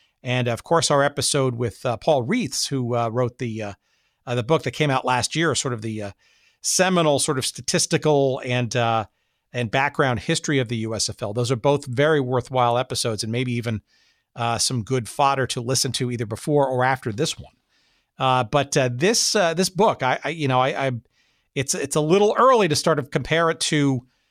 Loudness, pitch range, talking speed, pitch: -21 LUFS, 120-150 Hz, 205 wpm, 130 Hz